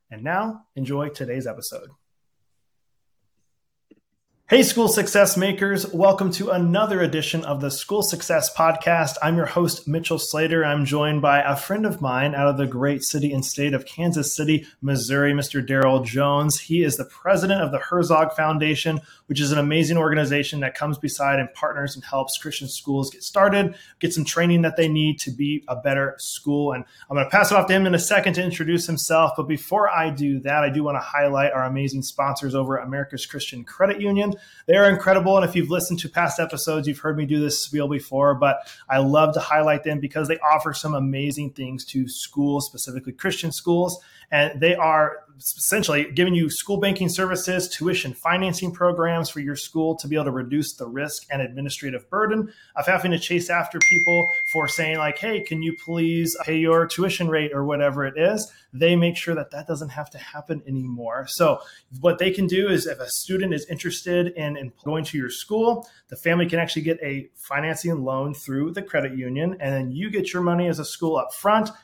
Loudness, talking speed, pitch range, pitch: -22 LUFS, 200 wpm, 140-175 Hz, 155 Hz